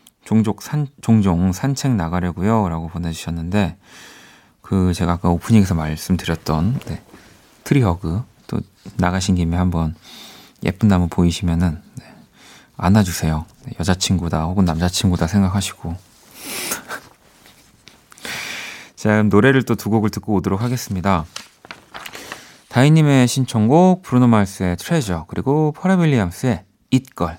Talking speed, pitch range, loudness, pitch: 280 characters per minute, 85-120 Hz, -18 LUFS, 95 Hz